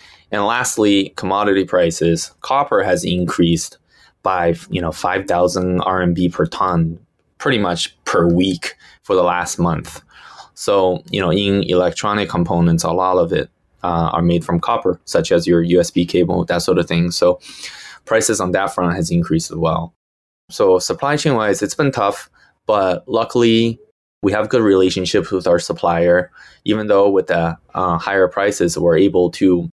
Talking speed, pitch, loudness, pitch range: 165 wpm, 90 Hz, -17 LUFS, 85-100 Hz